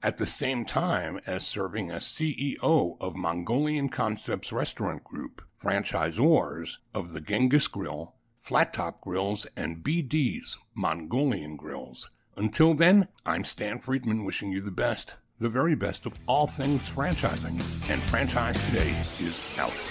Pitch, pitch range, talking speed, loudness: 110 Hz, 95-140 Hz, 140 wpm, -28 LUFS